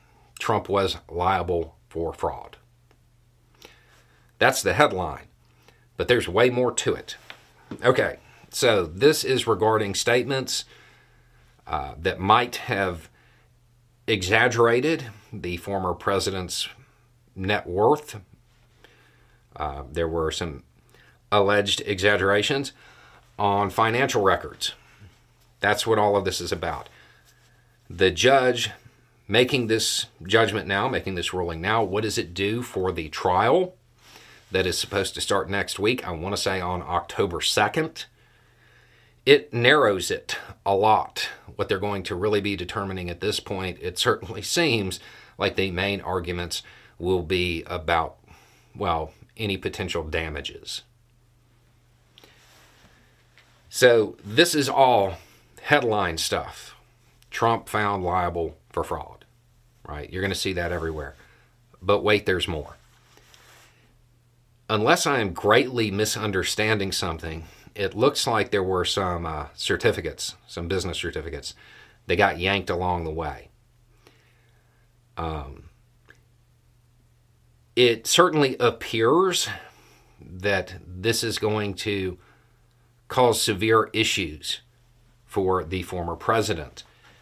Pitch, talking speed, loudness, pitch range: 110 Hz, 115 wpm, -24 LUFS, 95-120 Hz